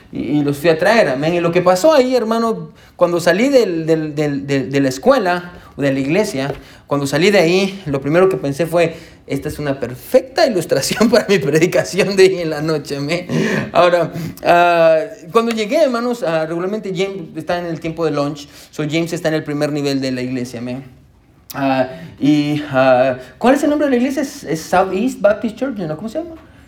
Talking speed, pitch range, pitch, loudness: 210 wpm, 145-195 Hz, 165 Hz, -16 LUFS